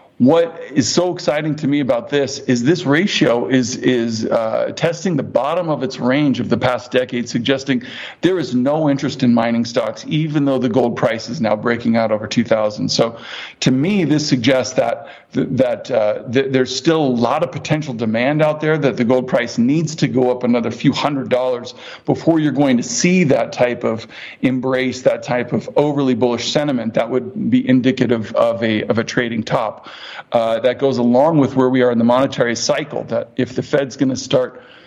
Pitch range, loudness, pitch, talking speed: 120-145 Hz, -17 LUFS, 130 Hz, 210 wpm